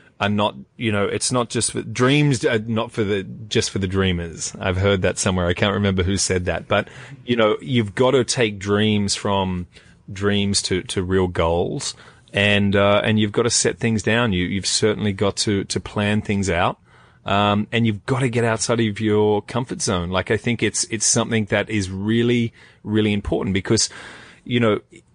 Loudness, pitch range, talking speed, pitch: -20 LUFS, 100-115 Hz, 200 wpm, 105 Hz